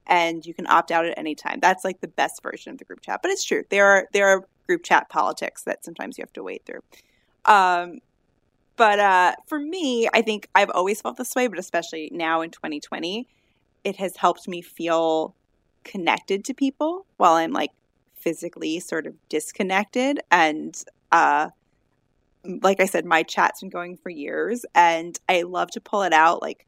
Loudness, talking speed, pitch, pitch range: -22 LUFS, 190 wpm, 190 Hz, 170-245 Hz